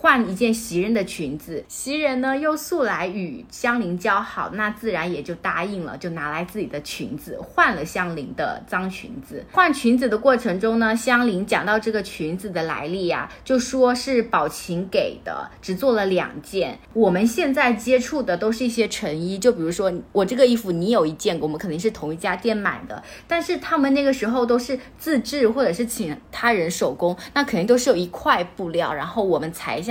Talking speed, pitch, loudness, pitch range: 300 characters per minute, 220 Hz, -22 LUFS, 180-250 Hz